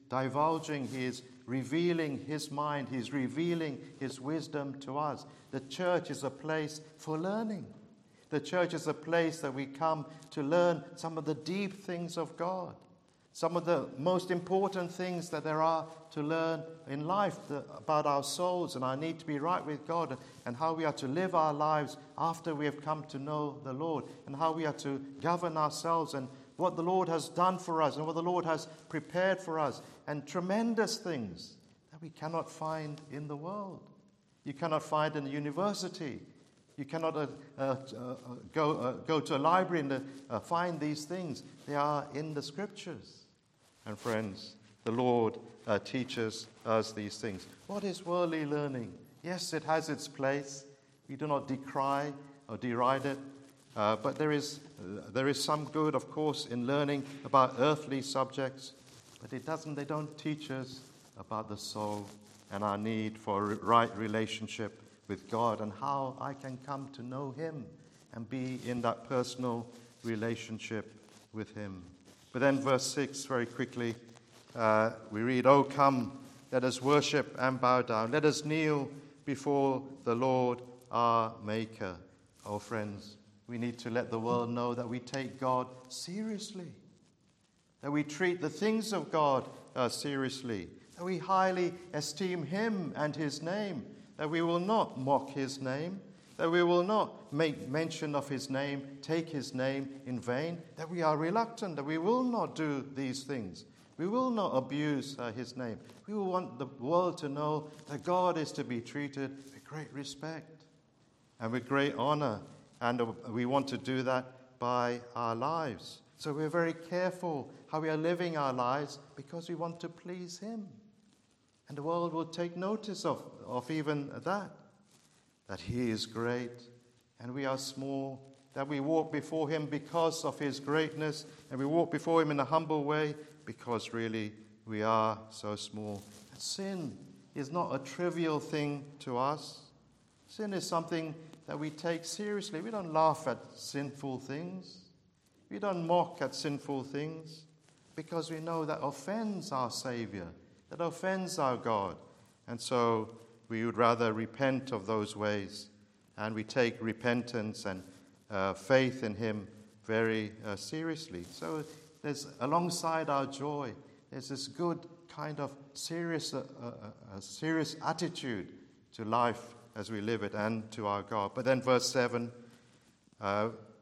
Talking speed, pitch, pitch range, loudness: 165 wpm, 140 Hz, 120-160 Hz, -35 LUFS